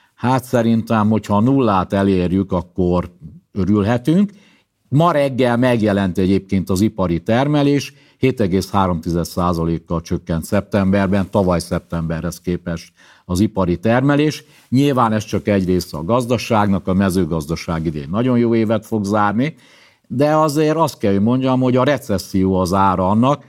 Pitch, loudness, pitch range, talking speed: 100 Hz, -17 LUFS, 90-125 Hz, 130 wpm